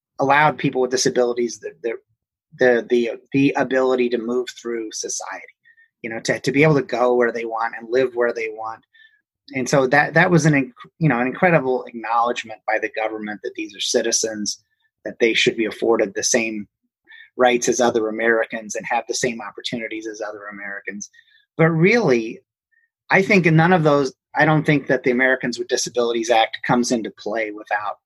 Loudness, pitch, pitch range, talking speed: -19 LUFS, 125 Hz, 115-160 Hz, 190 wpm